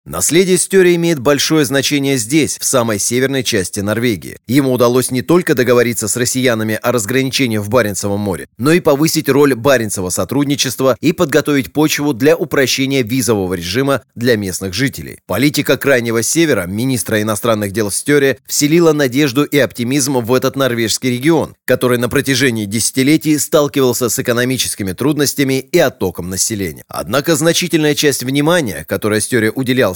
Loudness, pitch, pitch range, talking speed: -14 LUFS, 130 Hz, 115-145 Hz, 145 wpm